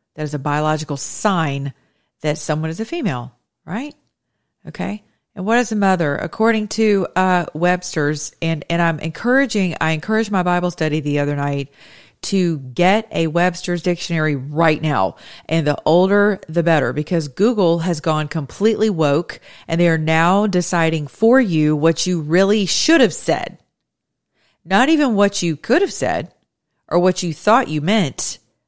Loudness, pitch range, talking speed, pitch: -18 LUFS, 155-195 Hz, 160 wpm, 170 Hz